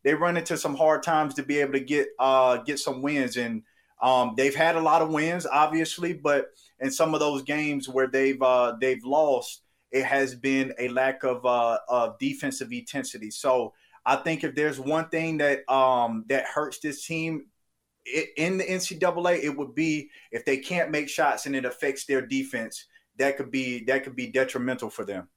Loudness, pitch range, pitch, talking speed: -26 LUFS, 130-160 Hz, 140 Hz, 200 wpm